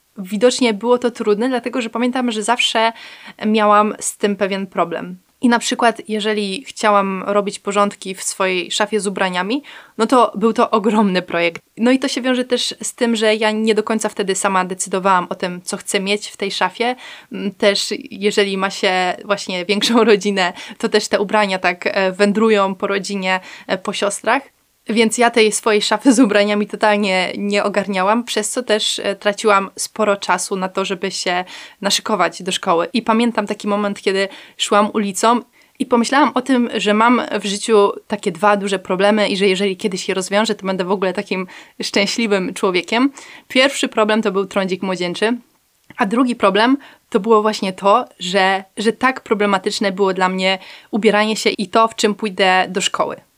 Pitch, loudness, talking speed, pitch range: 210 Hz, -17 LUFS, 175 wpm, 195-225 Hz